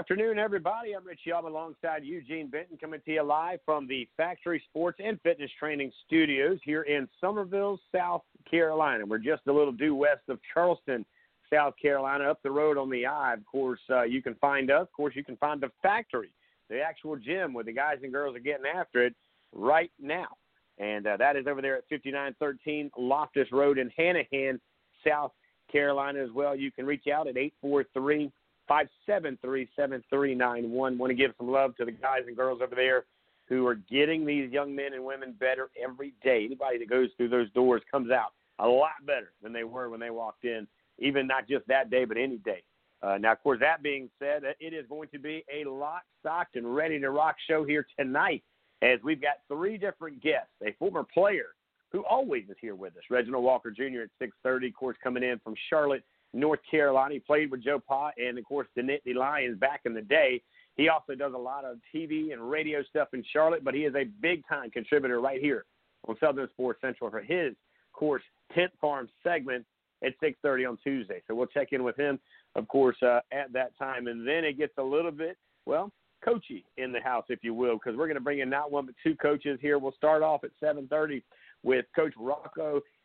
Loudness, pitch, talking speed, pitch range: -30 LUFS, 140 Hz, 210 wpm, 130-155 Hz